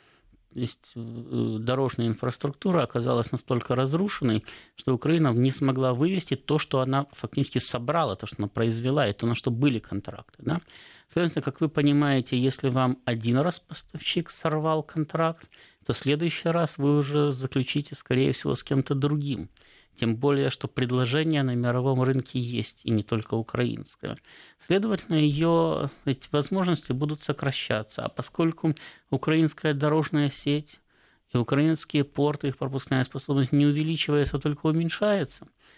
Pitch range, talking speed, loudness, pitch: 125-155 Hz, 145 wpm, -26 LUFS, 140 Hz